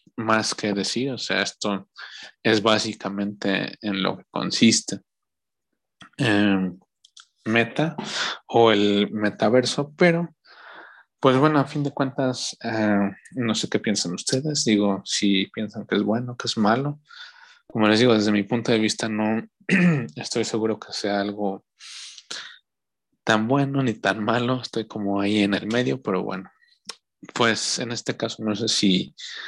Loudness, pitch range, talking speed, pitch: -23 LUFS, 105-130 Hz, 150 wpm, 110 Hz